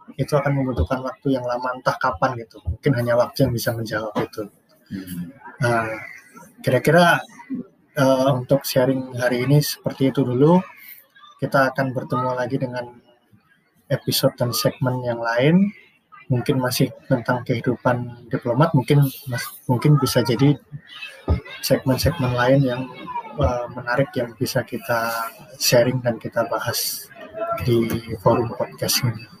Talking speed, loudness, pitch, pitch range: 125 wpm, -21 LUFS, 130 Hz, 120-140 Hz